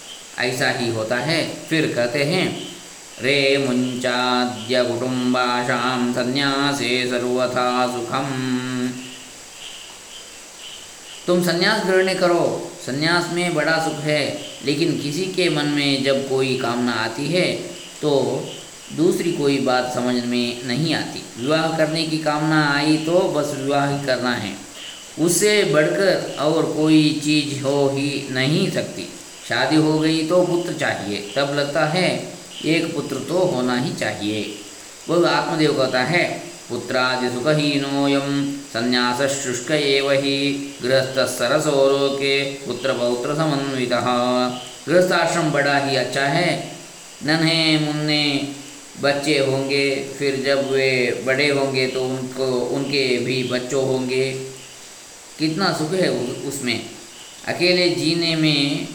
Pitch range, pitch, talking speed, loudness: 125-155 Hz, 140 Hz, 120 wpm, -20 LUFS